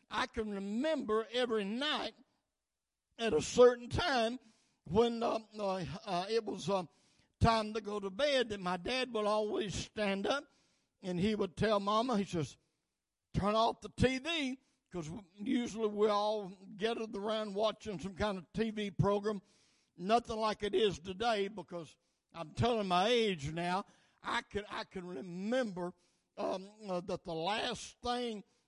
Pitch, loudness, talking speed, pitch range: 210 Hz, -35 LUFS, 155 wpm, 190-230 Hz